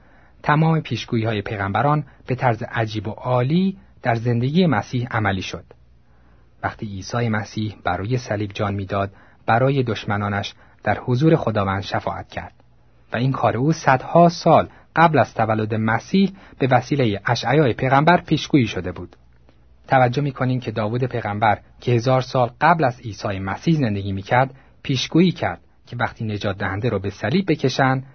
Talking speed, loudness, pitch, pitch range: 150 wpm, -20 LUFS, 115 Hz, 100-135 Hz